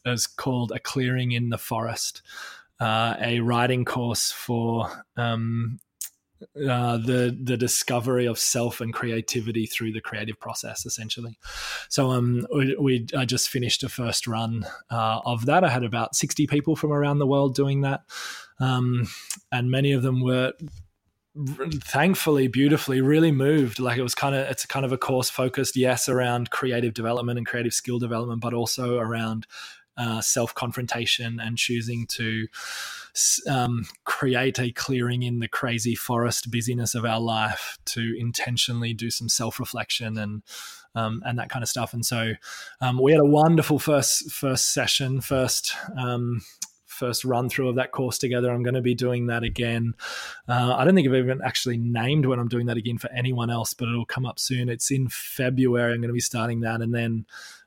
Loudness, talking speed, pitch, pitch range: -24 LUFS, 180 wpm, 120 Hz, 115-130 Hz